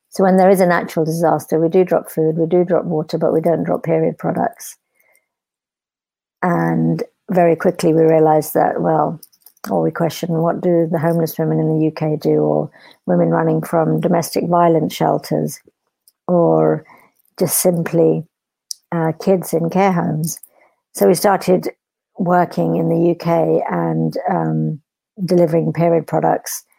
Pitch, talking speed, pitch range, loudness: 165 Hz, 150 wpm, 155-175 Hz, -16 LUFS